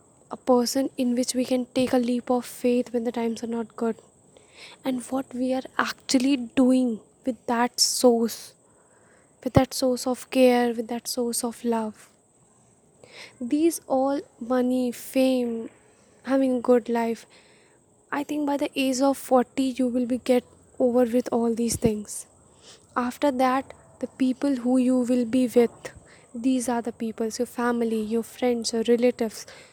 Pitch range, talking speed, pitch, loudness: 240-260 Hz, 160 wpm, 250 Hz, -25 LUFS